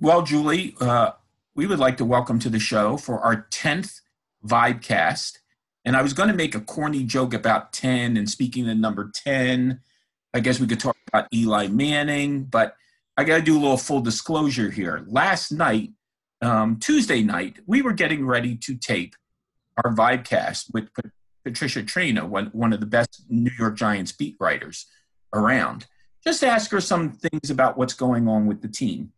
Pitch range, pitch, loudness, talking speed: 115-150 Hz, 125 Hz, -22 LUFS, 180 wpm